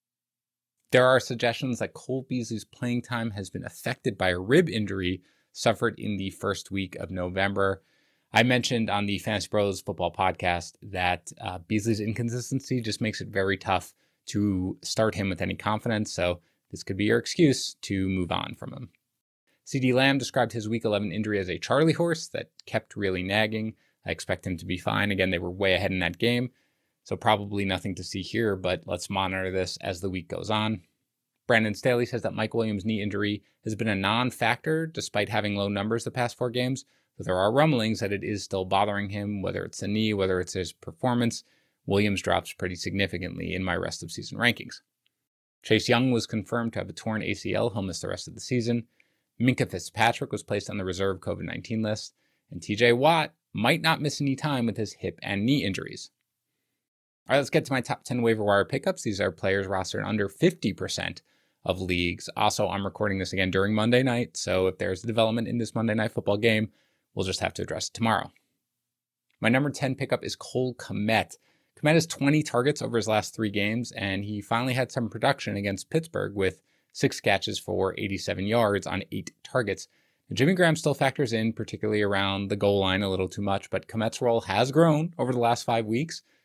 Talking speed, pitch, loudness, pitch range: 205 wpm, 105 Hz, -27 LUFS, 95-120 Hz